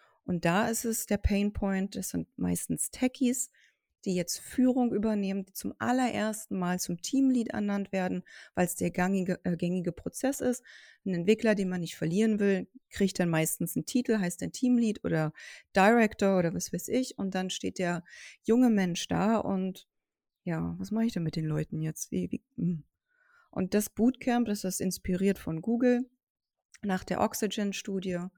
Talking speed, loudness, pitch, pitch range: 170 wpm, -30 LUFS, 200 Hz, 180-230 Hz